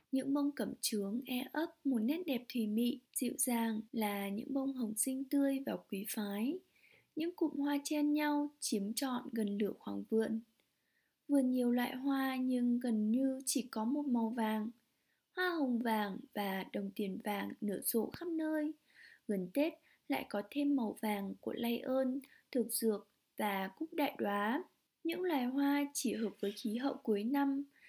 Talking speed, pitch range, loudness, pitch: 175 wpm, 220-280 Hz, -37 LUFS, 250 Hz